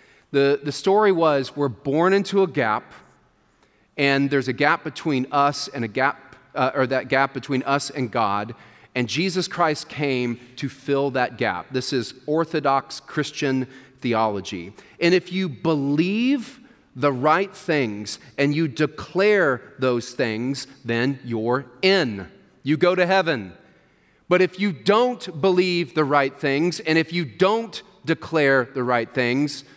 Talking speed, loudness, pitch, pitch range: 150 wpm, -22 LUFS, 140 Hz, 130-170 Hz